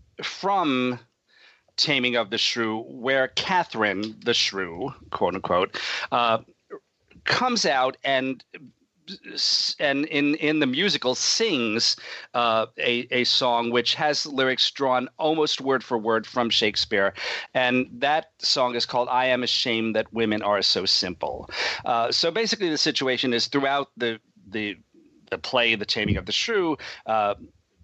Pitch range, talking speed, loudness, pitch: 115-140 Hz, 140 wpm, -23 LUFS, 125 Hz